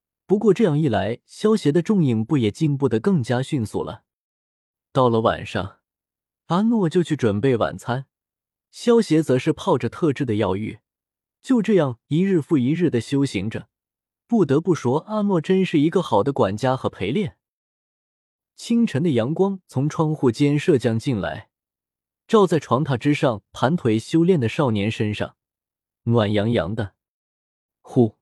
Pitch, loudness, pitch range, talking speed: 130 Hz, -21 LUFS, 105-165 Hz, 225 characters per minute